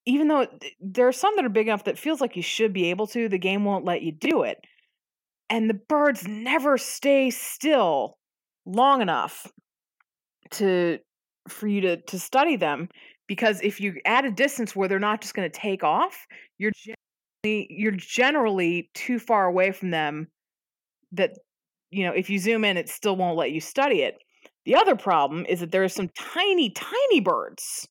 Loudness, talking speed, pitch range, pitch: -24 LUFS, 185 wpm, 185-260 Hz, 215 Hz